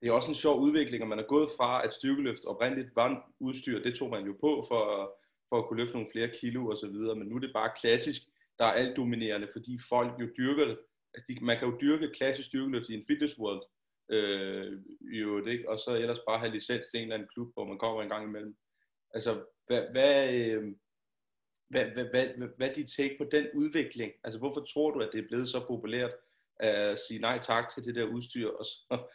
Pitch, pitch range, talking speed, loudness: 120 Hz, 110-140 Hz, 225 wpm, -32 LUFS